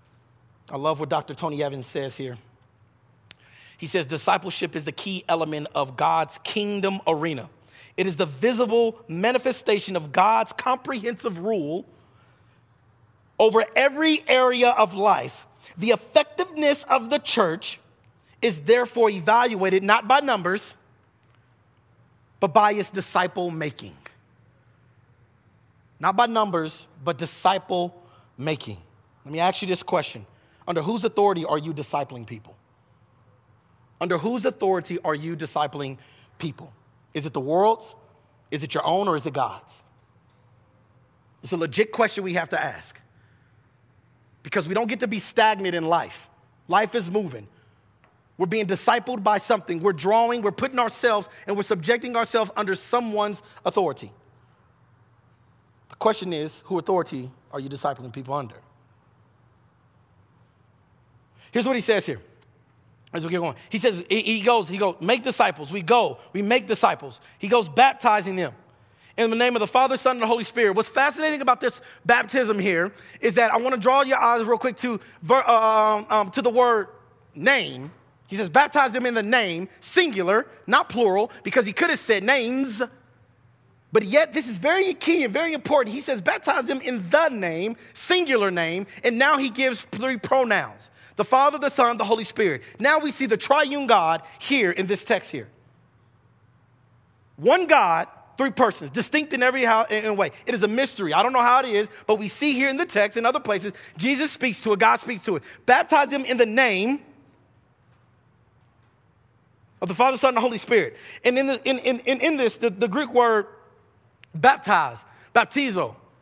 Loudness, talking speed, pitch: -22 LUFS, 165 wpm, 195 Hz